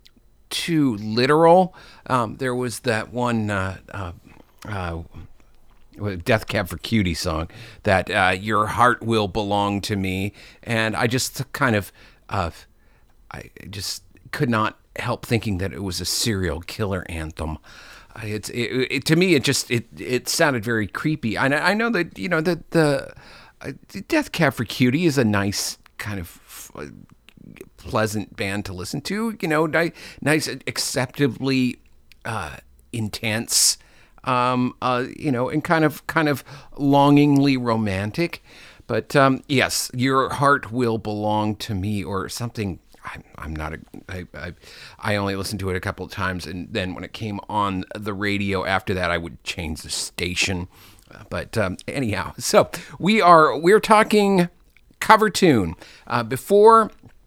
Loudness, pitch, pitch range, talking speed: -21 LUFS, 110 Hz, 100-135 Hz, 155 wpm